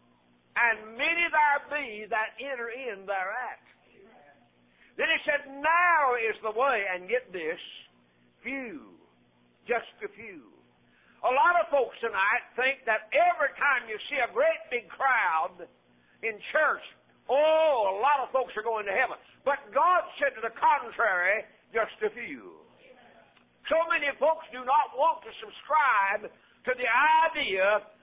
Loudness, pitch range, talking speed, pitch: -27 LUFS, 215-310 Hz, 145 wpm, 255 Hz